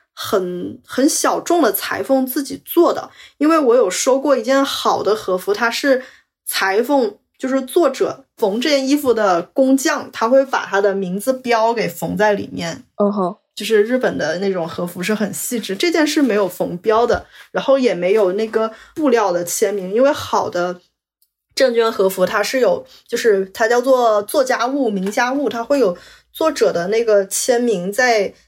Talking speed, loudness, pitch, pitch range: 255 characters per minute, -17 LUFS, 235 Hz, 205-270 Hz